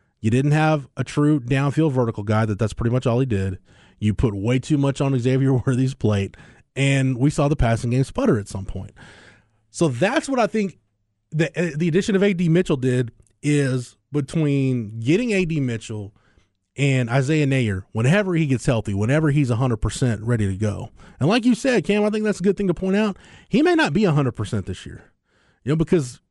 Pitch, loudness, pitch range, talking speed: 135 Hz, -21 LUFS, 110-165 Hz, 200 wpm